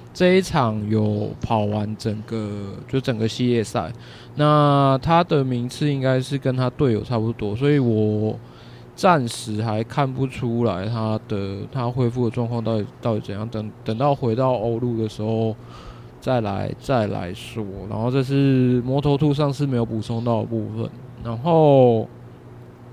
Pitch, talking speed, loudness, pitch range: 120 Hz, 230 characters per minute, -21 LUFS, 110-135 Hz